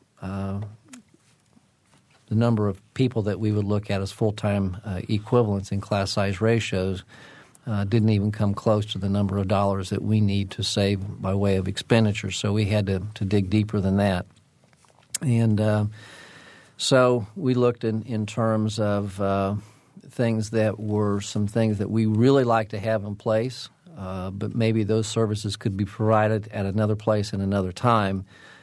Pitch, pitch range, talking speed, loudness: 105 Hz, 100-110 Hz, 175 wpm, -24 LUFS